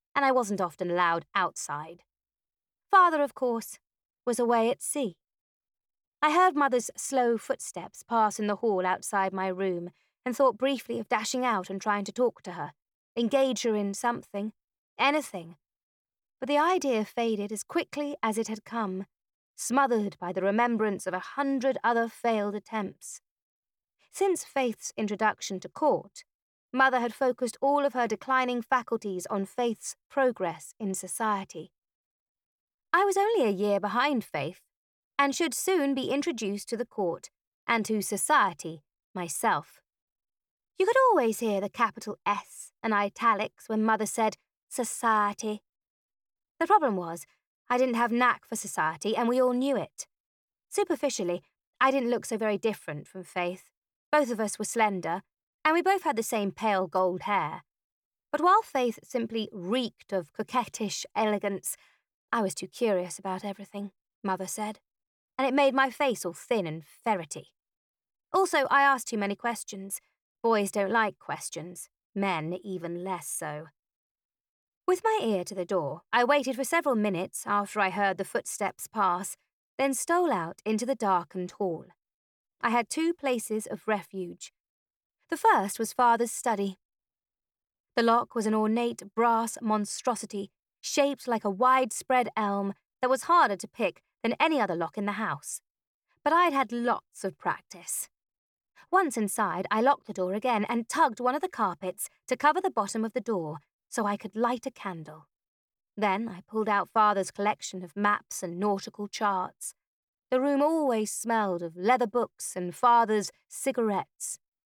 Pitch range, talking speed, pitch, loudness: 200-260 Hz, 155 wpm, 225 Hz, -28 LUFS